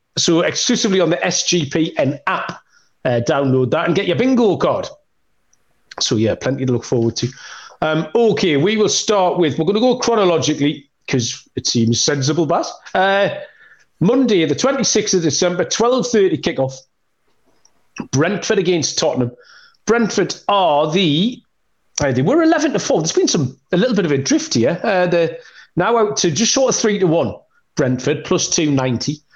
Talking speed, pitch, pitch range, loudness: 175 wpm, 175 Hz, 145-215 Hz, -16 LUFS